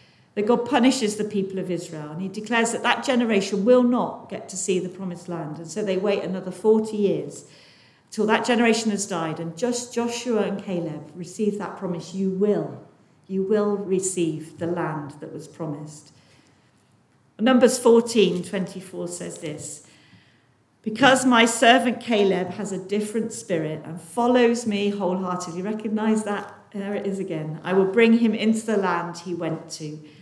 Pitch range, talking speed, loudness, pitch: 170-220 Hz, 165 wpm, -23 LUFS, 195 Hz